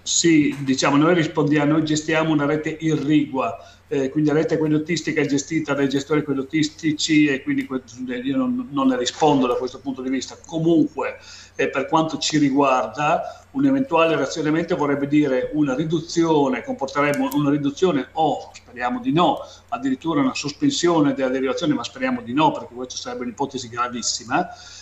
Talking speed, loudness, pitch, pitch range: 160 wpm, -21 LUFS, 150 Hz, 140-170 Hz